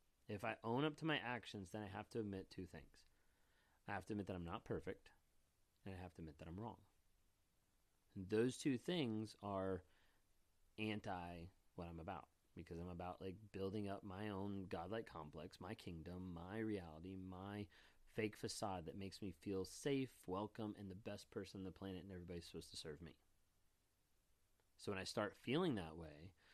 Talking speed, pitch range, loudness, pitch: 185 wpm, 85-105 Hz, -49 LUFS, 95 Hz